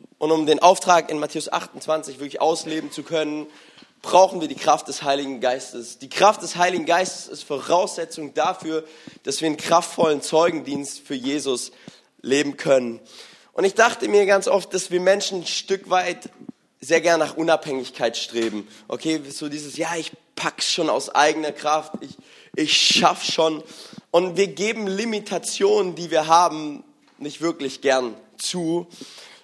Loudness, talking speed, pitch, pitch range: -21 LUFS, 155 wpm, 160 Hz, 145-180 Hz